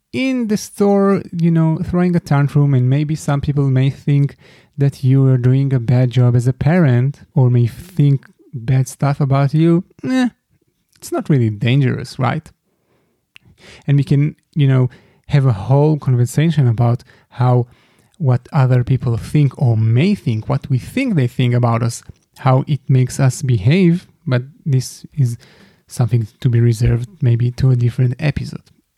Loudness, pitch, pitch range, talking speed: -16 LUFS, 135 Hz, 125-150 Hz, 165 wpm